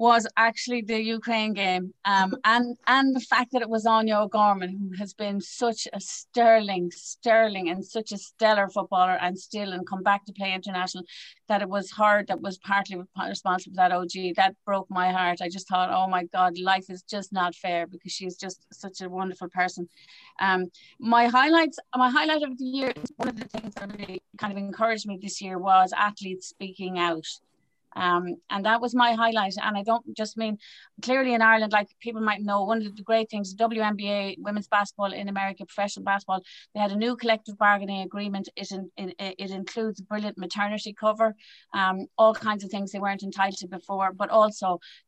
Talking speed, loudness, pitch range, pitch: 200 wpm, -25 LUFS, 190-220 Hz, 200 Hz